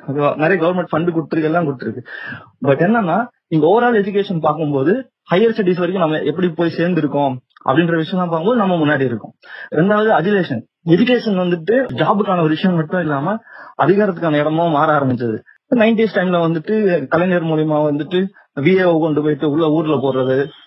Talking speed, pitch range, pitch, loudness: 135 wpm, 150-195 Hz, 170 Hz, -16 LUFS